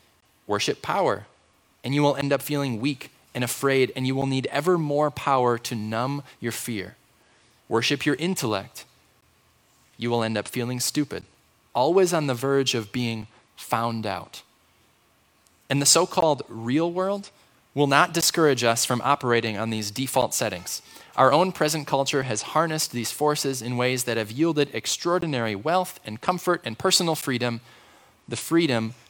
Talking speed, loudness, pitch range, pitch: 160 wpm, -24 LUFS, 115-150 Hz, 135 Hz